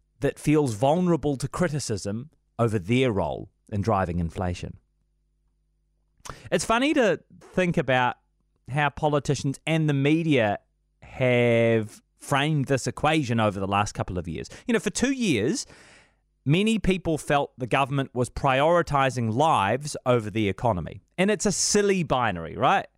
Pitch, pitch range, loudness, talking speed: 135 Hz, 110-155 Hz, -24 LUFS, 140 wpm